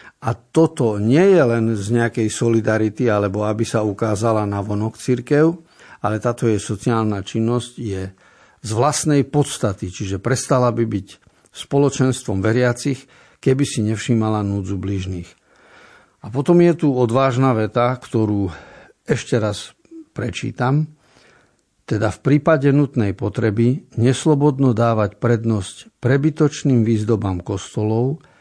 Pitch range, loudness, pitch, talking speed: 105-135 Hz, -19 LUFS, 120 Hz, 120 wpm